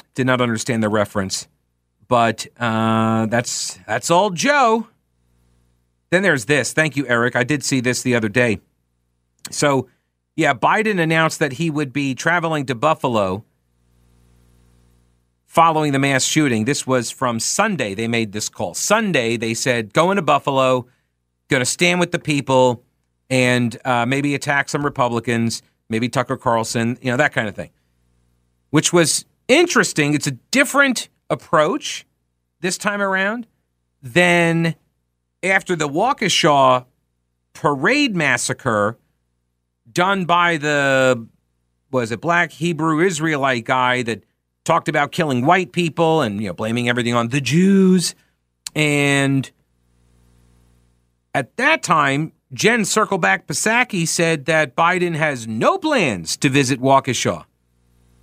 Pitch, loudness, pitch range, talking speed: 130 Hz, -18 LUFS, 100-160 Hz, 135 wpm